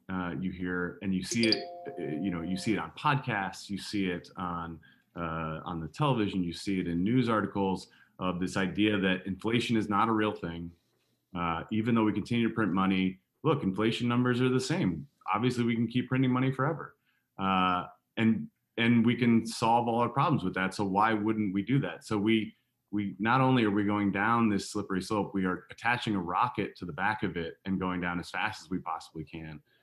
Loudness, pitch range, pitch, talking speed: -30 LUFS, 90-115 Hz, 100 Hz, 215 wpm